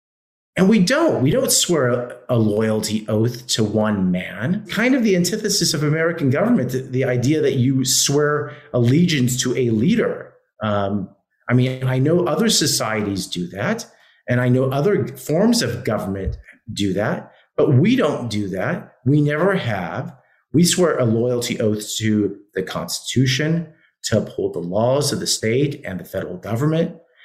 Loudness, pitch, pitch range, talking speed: -19 LUFS, 130 Hz, 110-165 Hz, 160 wpm